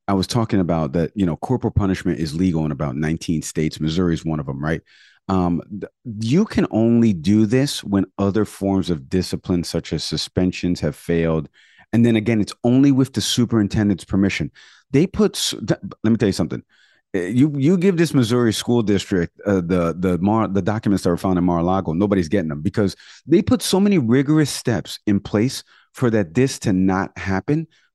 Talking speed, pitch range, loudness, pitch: 190 wpm, 85-120 Hz, -20 LUFS, 100 Hz